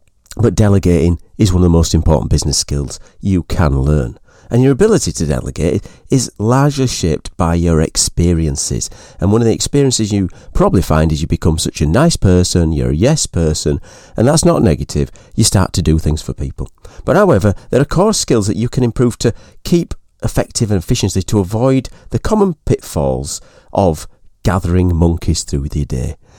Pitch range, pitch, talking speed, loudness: 80-115 Hz, 95 Hz, 180 wpm, -14 LUFS